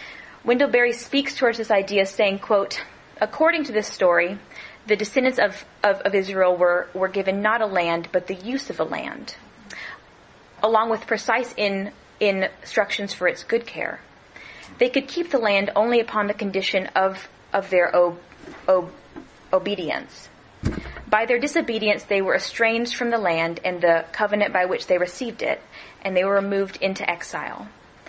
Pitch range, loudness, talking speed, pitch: 190-230 Hz, -22 LUFS, 165 wpm, 205 Hz